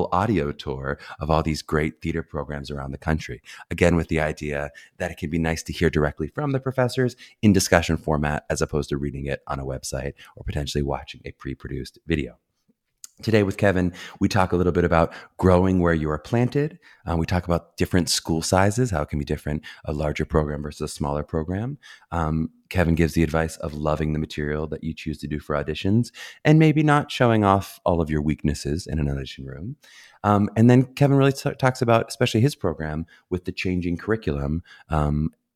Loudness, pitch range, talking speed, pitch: -23 LUFS, 75-100 Hz, 205 wpm, 80 Hz